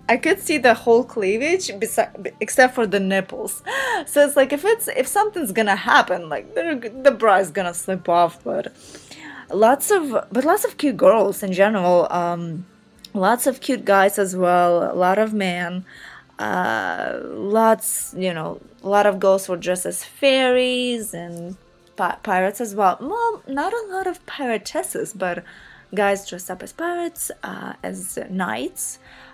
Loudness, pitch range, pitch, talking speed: -20 LUFS, 185-280 Hz, 220 Hz, 165 wpm